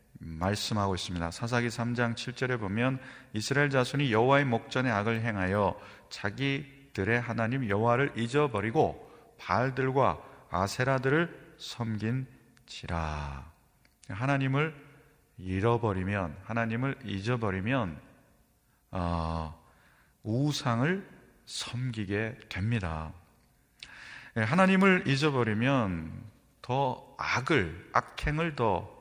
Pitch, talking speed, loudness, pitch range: 120 Hz, 220 characters per minute, -30 LUFS, 100-135 Hz